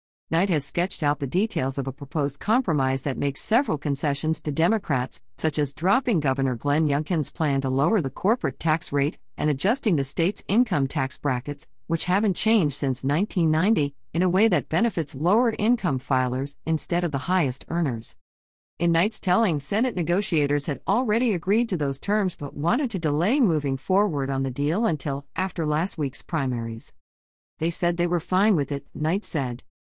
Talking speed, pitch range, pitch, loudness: 175 wpm, 140-185 Hz, 155 Hz, -25 LUFS